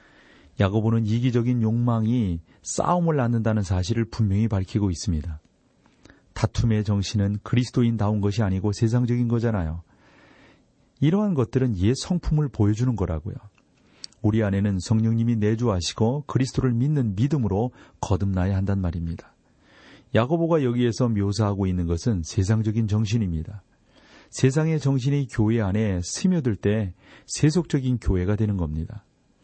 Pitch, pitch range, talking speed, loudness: 110 Hz, 100-125 Hz, 330 characters per minute, -24 LUFS